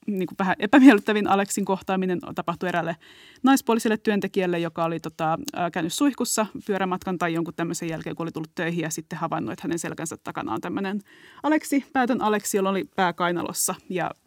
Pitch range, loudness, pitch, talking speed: 170-215 Hz, -24 LUFS, 185 Hz, 170 wpm